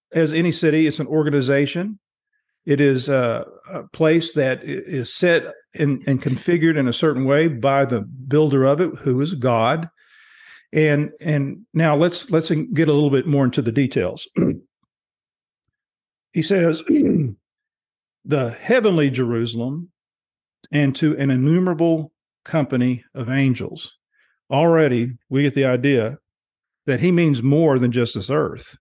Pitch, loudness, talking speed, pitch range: 150 Hz, -19 LUFS, 140 wpm, 135-165 Hz